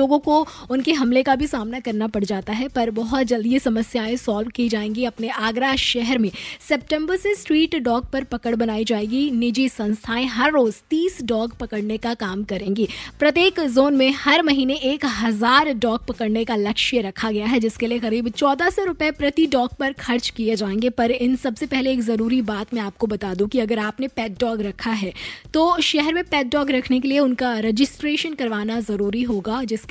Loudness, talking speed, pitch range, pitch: -21 LUFS, 195 wpm, 225-275 Hz, 245 Hz